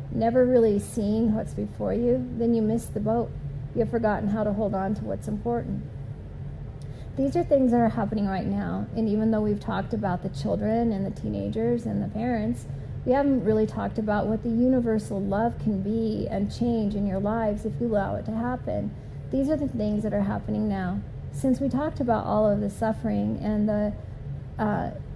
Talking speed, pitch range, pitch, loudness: 200 wpm, 170-225 Hz, 210 Hz, -26 LUFS